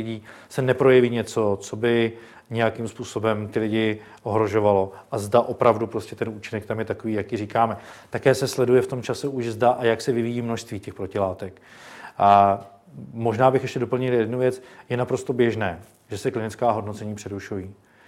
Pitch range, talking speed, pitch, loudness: 105-125 Hz, 175 wpm, 115 Hz, -23 LUFS